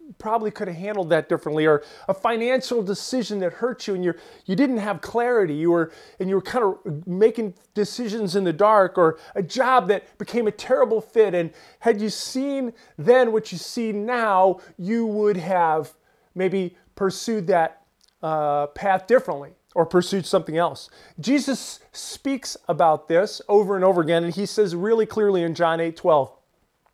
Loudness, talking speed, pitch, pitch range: -22 LUFS, 175 wpm, 200 Hz, 170-230 Hz